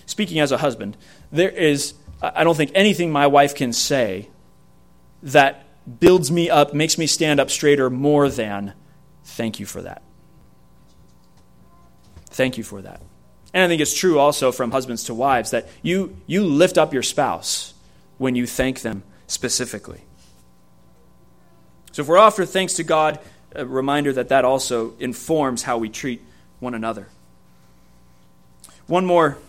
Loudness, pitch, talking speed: -19 LUFS, 130 Hz, 155 wpm